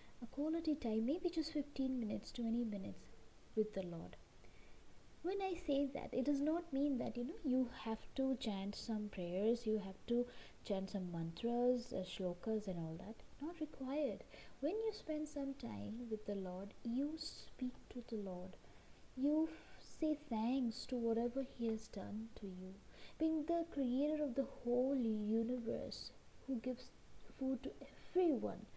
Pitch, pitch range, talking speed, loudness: 245 Hz, 215-280 Hz, 160 wpm, -42 LUFS